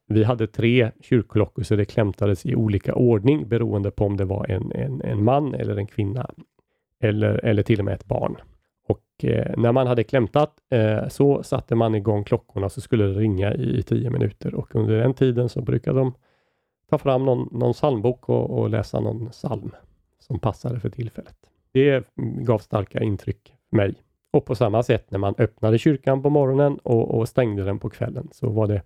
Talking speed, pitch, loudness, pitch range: 195 wpm, 115 Hz, -22 LUFS, 105-130 Hz